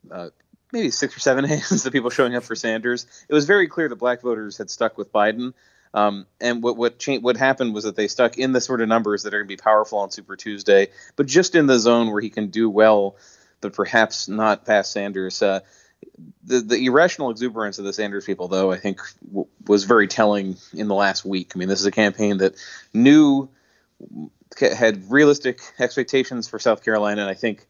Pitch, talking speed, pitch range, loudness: 110 Hz, 215 wpm, 100-125 Hz, -20 LUFS